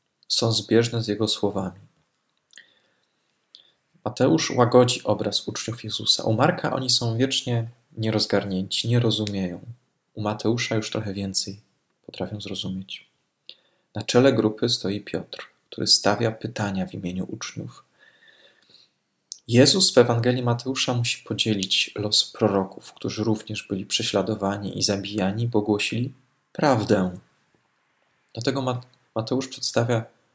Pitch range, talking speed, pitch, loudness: 100-120 Hz, 110 wpm, 110 Hz, -23 LUFS